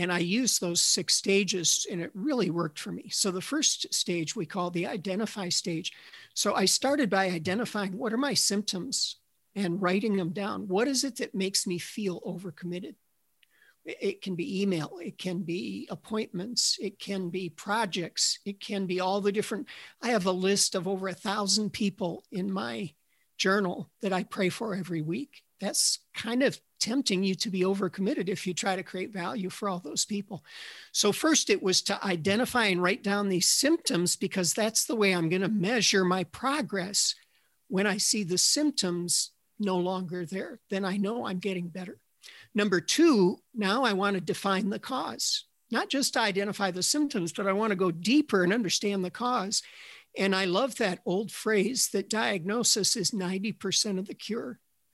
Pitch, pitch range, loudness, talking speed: 195 Hz, 185-220 Hz, -28 LUFS, 185 wpm